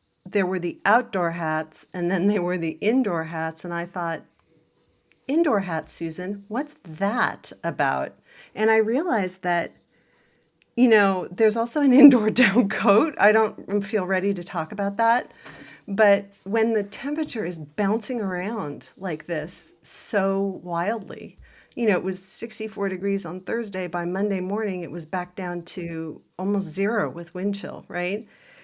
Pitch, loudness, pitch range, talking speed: 195 Hz, -24 LUFS, 175-220 Hz, 155 wpm